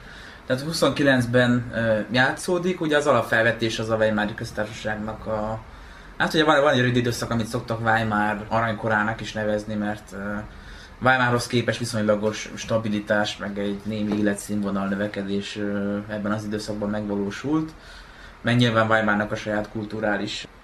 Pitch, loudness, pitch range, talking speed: 110 Hz, -23 LUFS, 105-115 Hz, 125 wpm